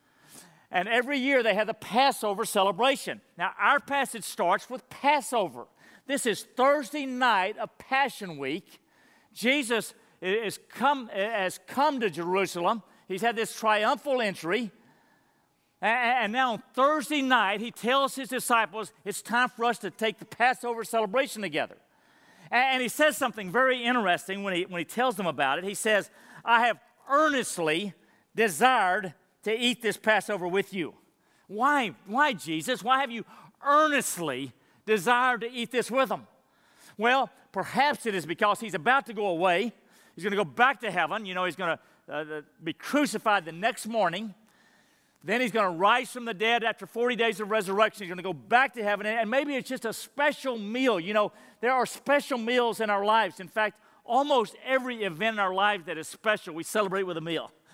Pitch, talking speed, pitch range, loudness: 225 Hz, 175 wpm, 195-255 Hz, -27 LUFS